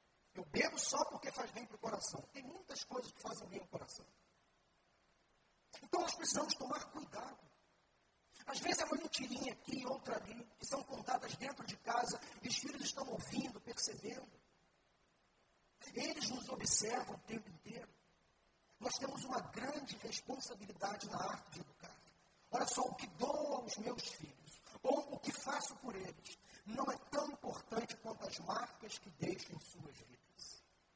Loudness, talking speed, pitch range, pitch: -43 LUFS, 160 wpm, 215-275 Hz, 250 Hz